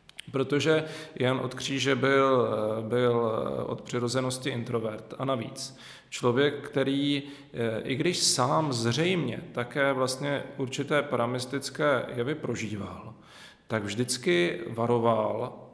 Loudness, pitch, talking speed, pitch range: -28 LUFS, 130 Hz, 100 wpm, 120-140 Hz